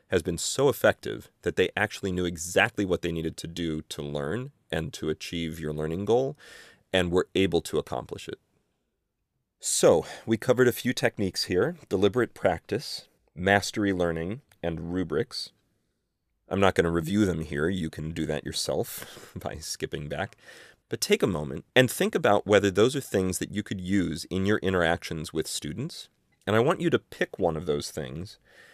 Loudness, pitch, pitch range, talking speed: -27 LUFS, 90 Hz, 80-105 Hz, 180 wpm